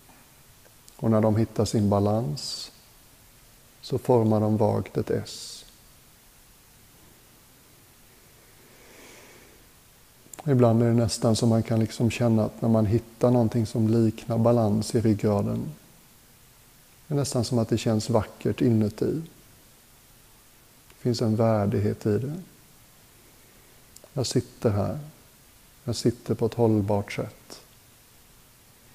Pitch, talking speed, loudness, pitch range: 115 Hz, 115 wpm, -25 LUFS, 110-125 Hz